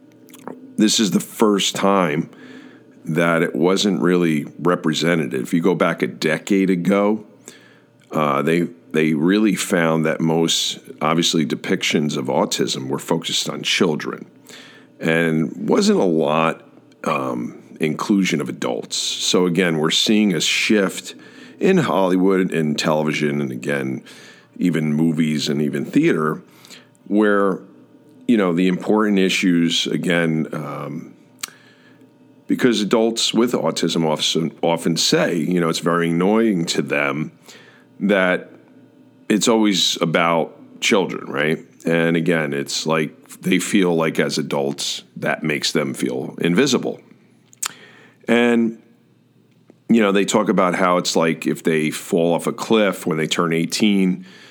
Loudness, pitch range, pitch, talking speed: -19 LUFS, 80-95 Hz, 85 Hz, 130 wpm